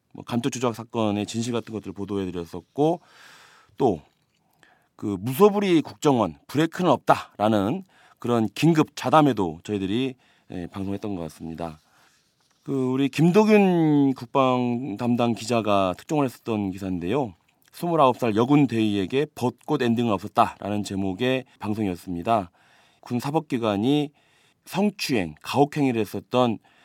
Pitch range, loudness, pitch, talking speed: 100-140 Hz, -24 LUFS, 120 Hz, 290 characters per minute